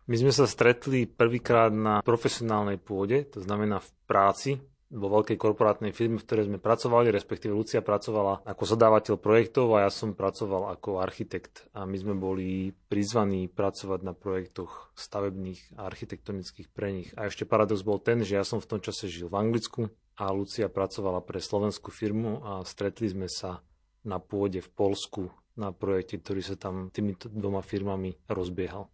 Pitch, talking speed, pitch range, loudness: 100 Hz, 170 wpm, 95-110 Hz, -29 LUFS